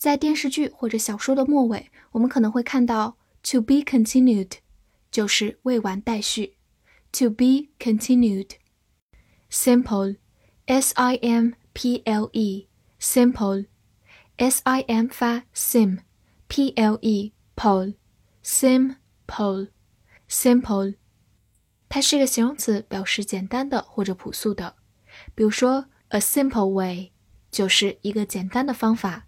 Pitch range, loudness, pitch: 200-250 Hz, -22 LUFS, 225 Hz